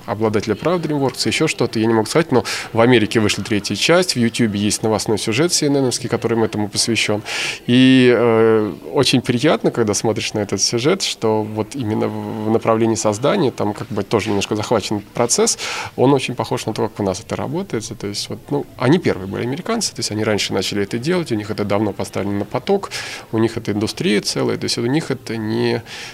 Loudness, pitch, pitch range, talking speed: -18 LUFS, 115 Hz, 105-125 Hz, 205 wpm